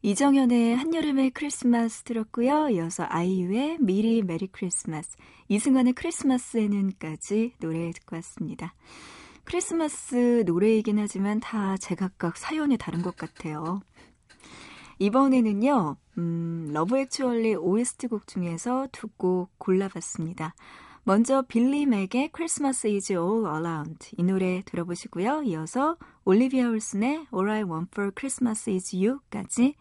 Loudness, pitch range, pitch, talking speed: -26 LUFS, 180-255 Hz, 215 Hz, 315 characters per minute